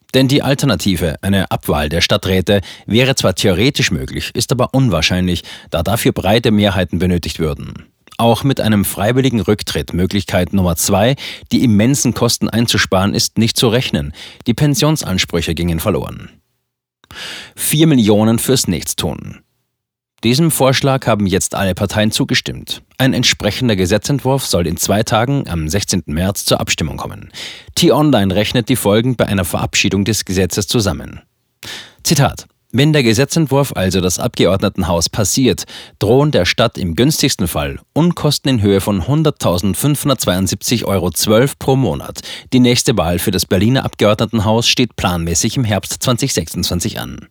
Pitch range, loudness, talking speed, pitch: 95-125 Hz, -14 LUFS, 140 wpm, 105 Hz